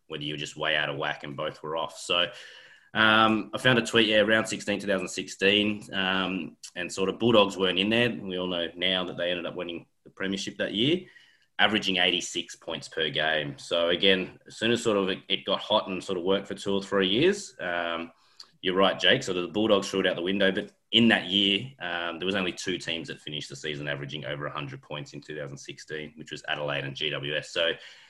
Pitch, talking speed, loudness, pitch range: 95 Hz, 230 wpm, -26 LUFS, 85-100 Hz